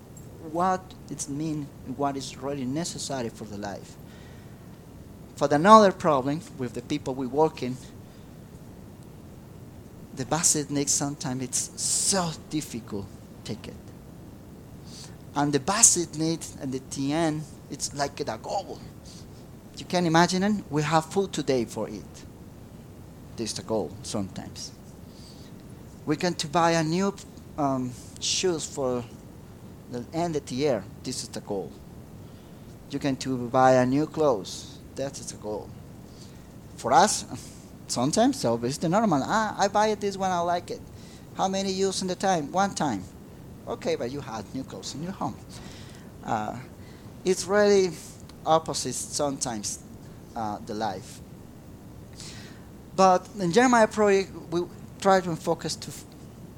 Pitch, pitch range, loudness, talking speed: 145 Hz, 125-175 Hz, -26 LUFS, 145 wpm